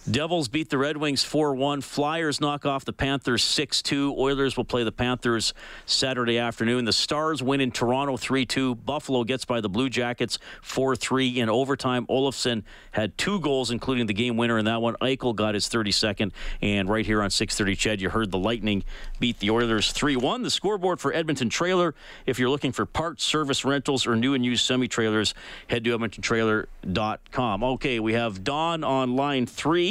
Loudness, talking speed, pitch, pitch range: -25 LUFS, 180 wpm, 125 Hz, 115-140 Hz